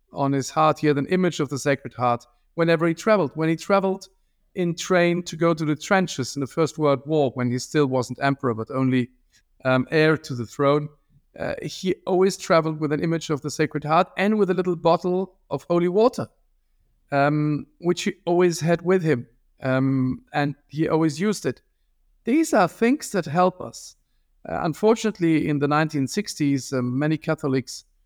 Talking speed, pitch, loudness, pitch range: 185 wpm, 155 Hz, -23 LUFS, 135-180 Hz